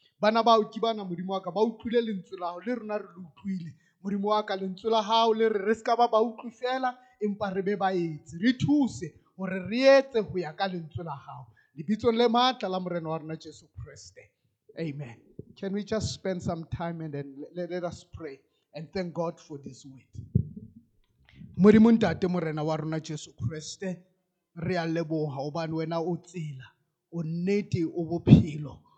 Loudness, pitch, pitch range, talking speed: -28 LUFS, 180 Hz, 160-215 Hz, 135 wpm